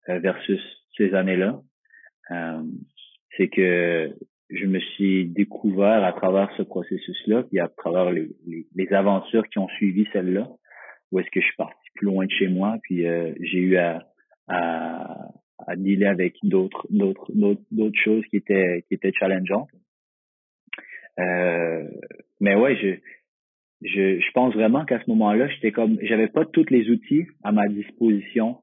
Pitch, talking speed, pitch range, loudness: 100 Hz, 155 wpm, 90-110 Hz, -22 LUFS